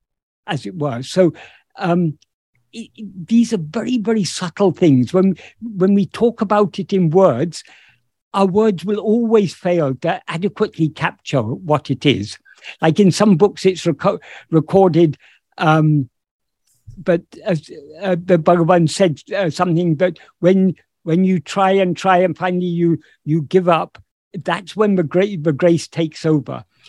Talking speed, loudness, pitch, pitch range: 155 wpm, -17 LUFS, 180 Hz, 160-195 Hz